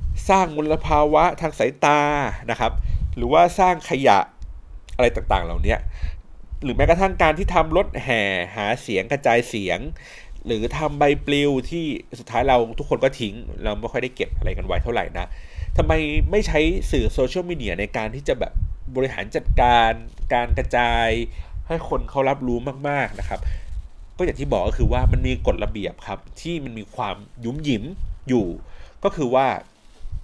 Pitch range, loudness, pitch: 100-145 Hz, -22 LUFS, 120 Hz